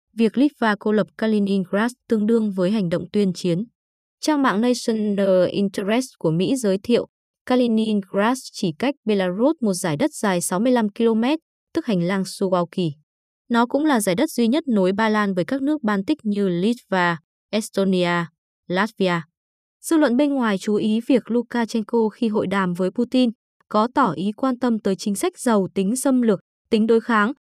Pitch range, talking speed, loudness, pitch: 195-240 Hz, 175 wpm, -21 LUFS, 215 Hz